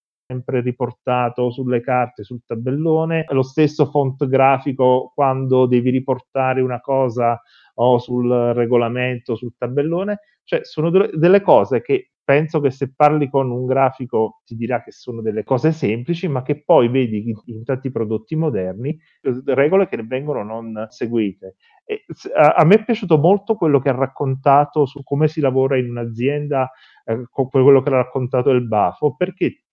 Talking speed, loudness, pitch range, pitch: 160 wpm, -18 LUFS, 125-145 Hz, 130 Hz